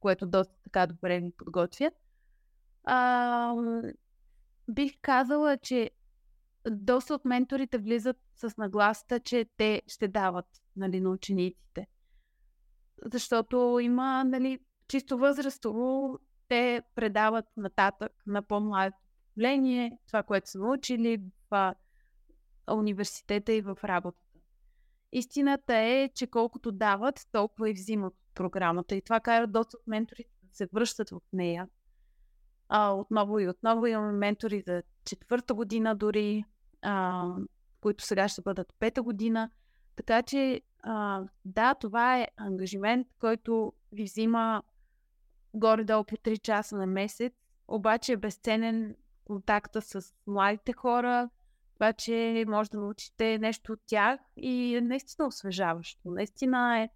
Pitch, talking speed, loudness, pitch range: 220 Hz, 125 wpm, -30 LUFS, 200-245 Hz